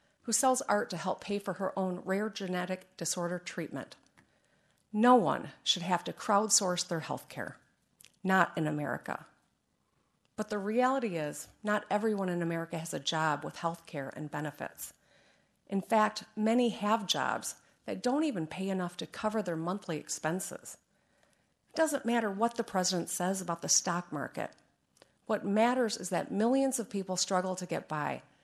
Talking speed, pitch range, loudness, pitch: 165 wpm, 170-220 Hz, -32 LUFS, 190 Hz